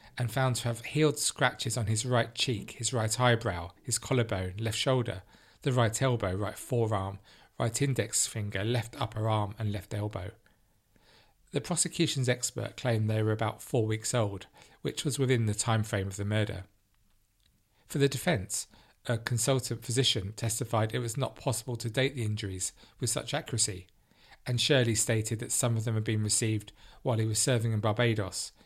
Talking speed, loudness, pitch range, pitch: 175 wpm, -30 LUFS, 105-125 Hz, 115 Hz